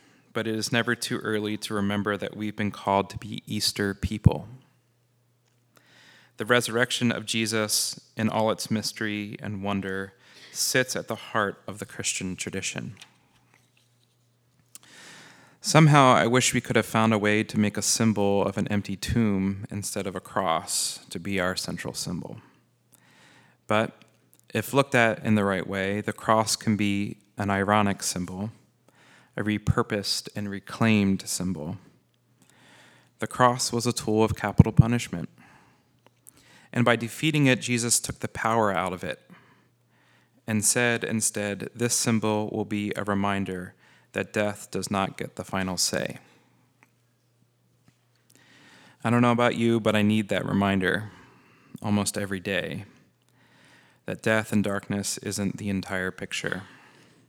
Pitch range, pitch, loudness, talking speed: 100-120 Hz, 110 Hz, -26 LUFS, 145 wpm